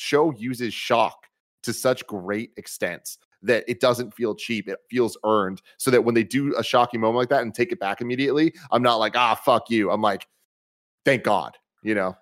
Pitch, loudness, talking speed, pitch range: 115 Hz, -23 LUFS, 210 wpm, 105-125 Hz